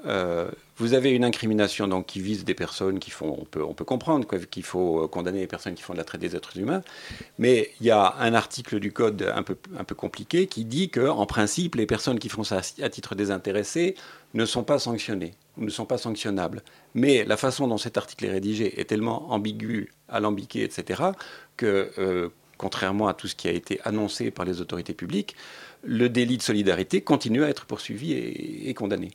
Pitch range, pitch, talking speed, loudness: 95-120 Hz, 105 Hz, 215 wpm, -26 LUFS